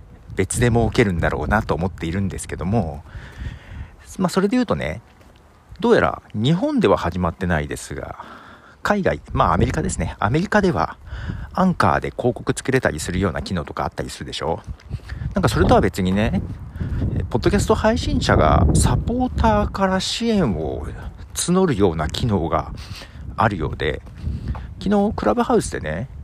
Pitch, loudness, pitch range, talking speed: 100 Hz, -20 LUFS, 85-130 Hz, 345 characters per minute